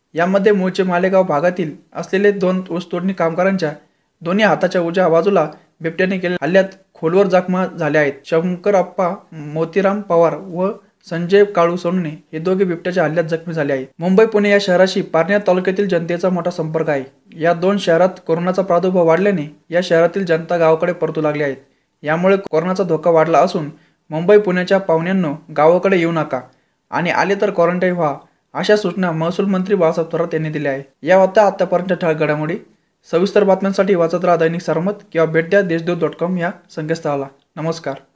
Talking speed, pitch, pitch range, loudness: 155 wpm, 175 Hz, 160-190 Hz, -16 LUFS